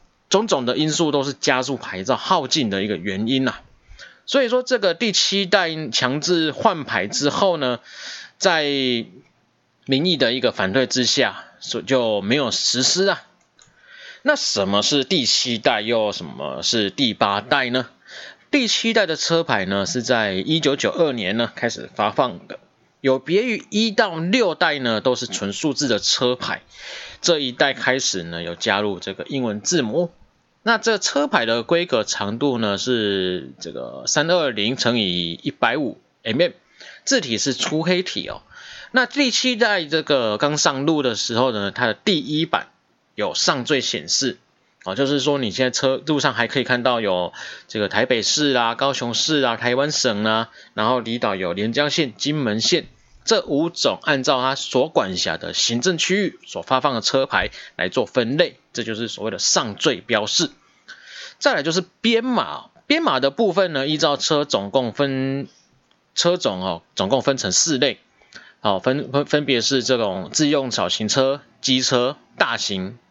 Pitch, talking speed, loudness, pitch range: 135 Hz, 240 characters per minute, -20 LUFS, 115-165 Hz